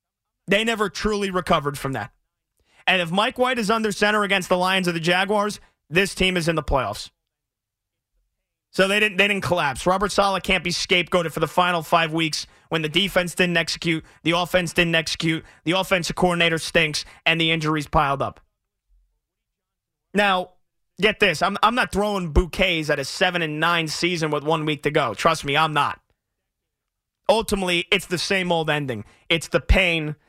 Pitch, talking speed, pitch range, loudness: 175 Hz, 180 wpm, 160-195 Hz, -21 LUFS